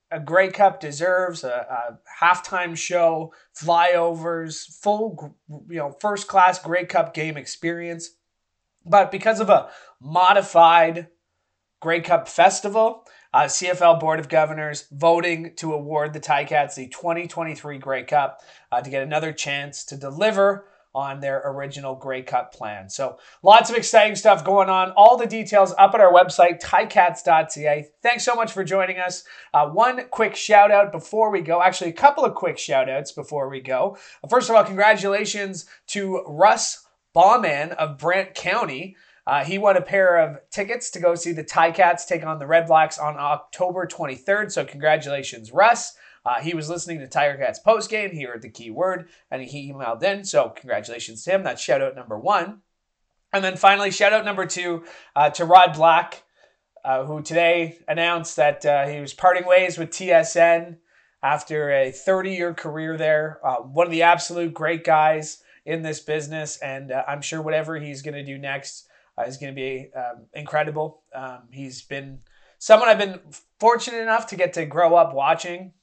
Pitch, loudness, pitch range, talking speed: 165 Hz, -20 LUFS, 150-185 Hz, 175 wpm